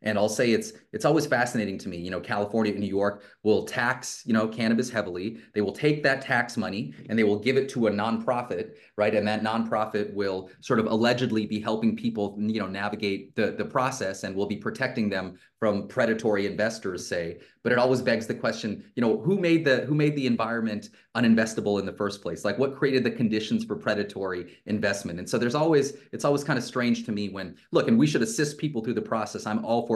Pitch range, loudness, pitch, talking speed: 105-120 Hz, -26 LUFS, 110 Hz, 225 wpm